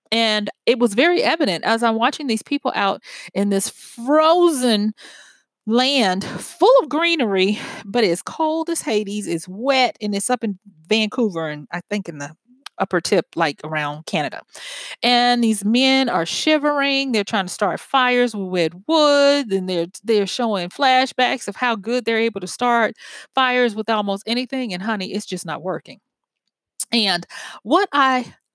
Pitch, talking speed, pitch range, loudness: 230 Hz, 160 wpm, 195-255 Hz, -19 LUFS